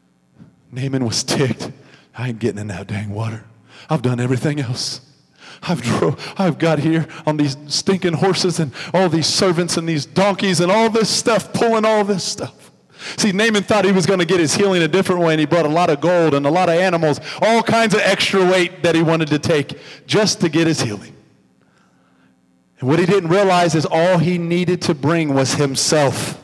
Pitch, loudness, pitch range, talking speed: 165 Hz, -17 LUFS, 140-190 Hz, 205 wpm